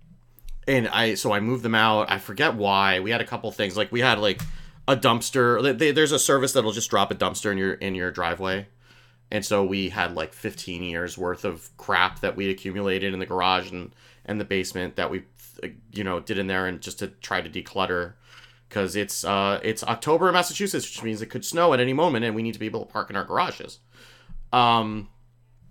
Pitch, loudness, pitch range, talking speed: 105 Hz, -24 LUFS, 95-120 Hz, 225 wpm